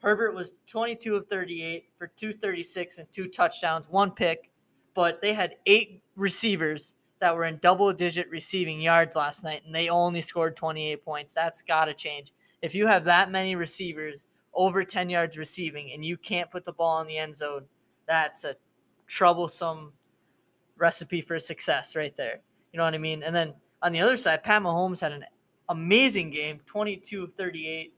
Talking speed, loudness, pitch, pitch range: 180 wpm, -27 LUFS, 170 Hz, 160-190 Hz